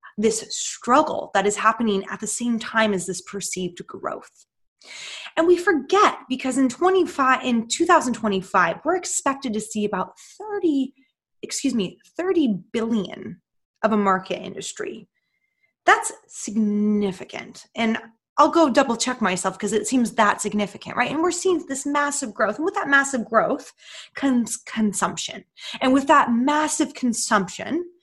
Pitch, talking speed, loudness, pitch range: 245 Hz, 145 wpm, -22 LUFS, 210-305 Hz